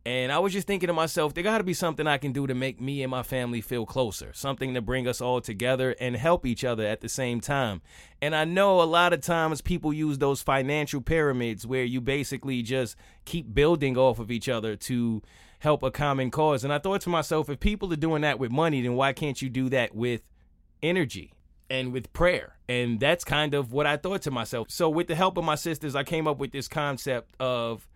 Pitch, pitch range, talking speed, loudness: 135 Hz, 125-155 Hz, 235 wpm, -27 LUFS